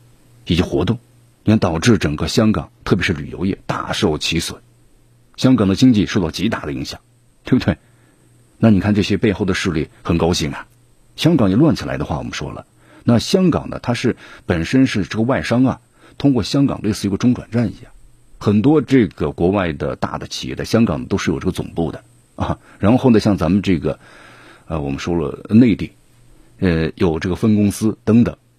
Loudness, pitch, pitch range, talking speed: -17 LUFS, 105 Hz, 90-120 Hz, 290 characters per minute